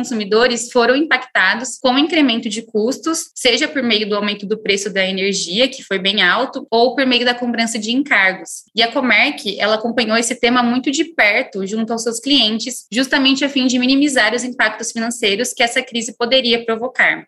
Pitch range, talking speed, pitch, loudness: 220-255 Hz, 190 wpm, 240 Hz, -15 LUFS